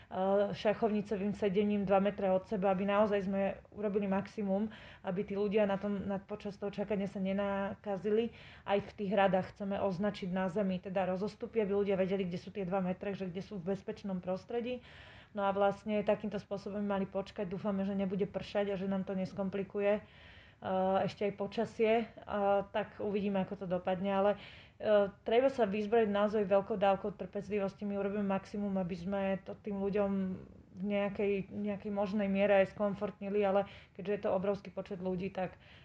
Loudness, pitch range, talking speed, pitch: -35 LUFS, 195-210 Hz, 170 wpm, 200 Hz